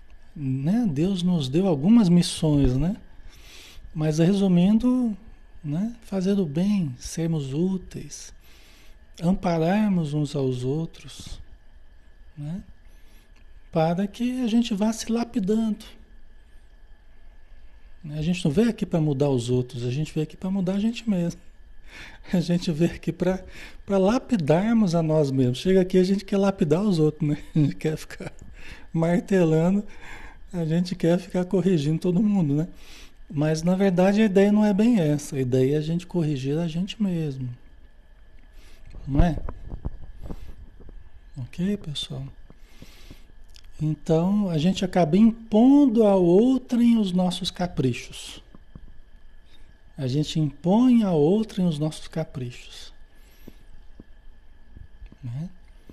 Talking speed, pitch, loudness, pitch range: 130 wpm, 165 Hz, -23 LUFS, 130-195 Hz